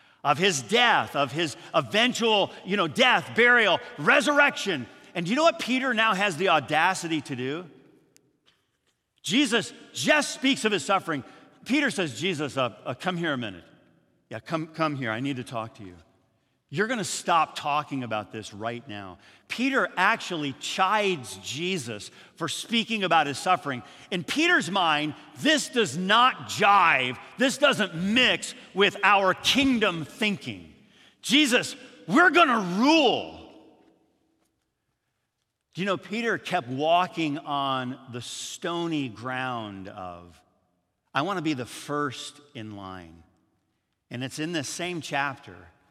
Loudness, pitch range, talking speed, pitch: -24 LUFS, 125-210 Hz, 145 wpm, 160 Hz